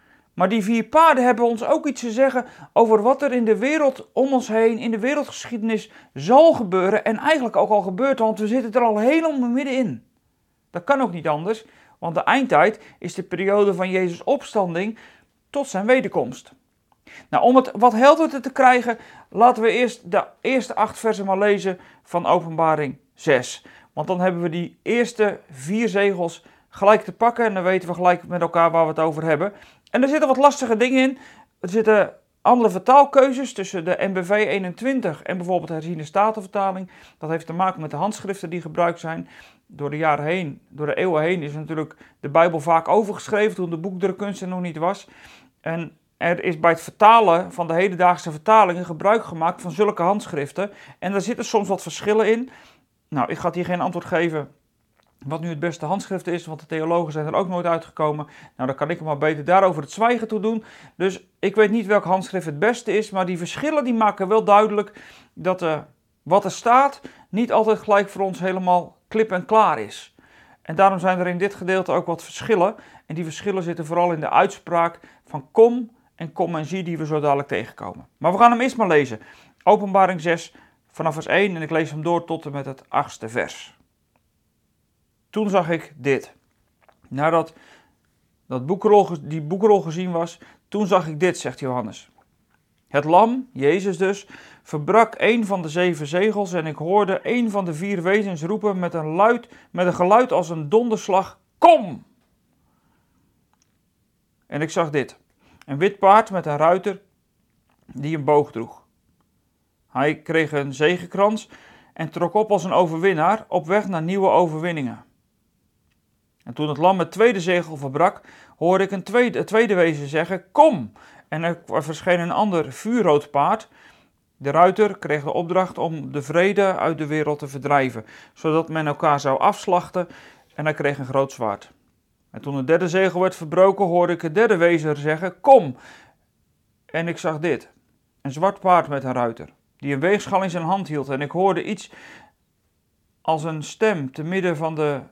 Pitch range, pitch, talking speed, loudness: 160-215 Hz, 185 Hz, 185 wpm, -20 LUFS